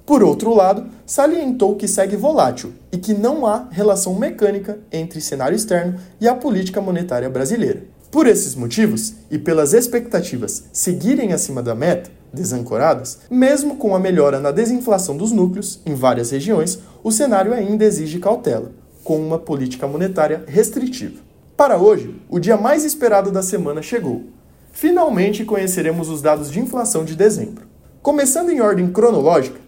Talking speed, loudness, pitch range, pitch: 150 wpm, -17 LUFS, 165-230 Hz, 205 Hz